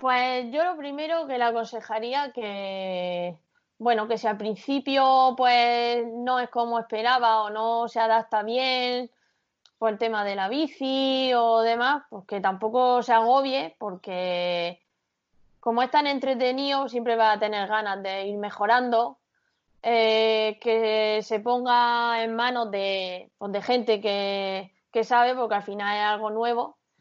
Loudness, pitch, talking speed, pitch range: -25 LUFS, 230 Hz, 150 wpm, 210-250 Hz